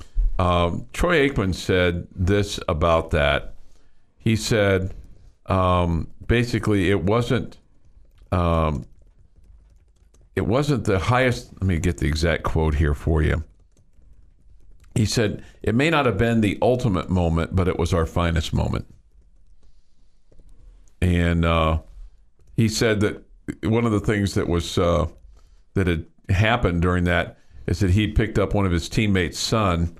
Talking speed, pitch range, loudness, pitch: 145 wpm, 85-105 Hz, -22 LUFS, 90 Hz